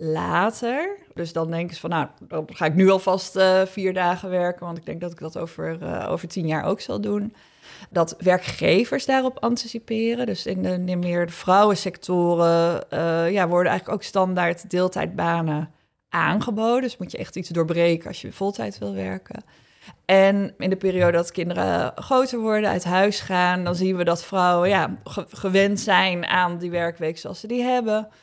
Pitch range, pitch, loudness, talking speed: 170-200 Hz, 180 Hz, -22 LUFS, 185 wpm